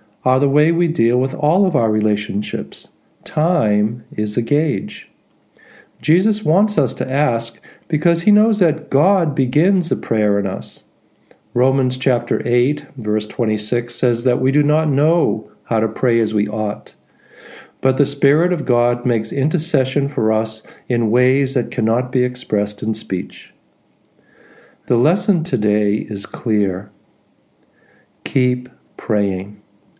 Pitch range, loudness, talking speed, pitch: 110-150 Hz, -17 LUFS, 140 wpm, 125 Hz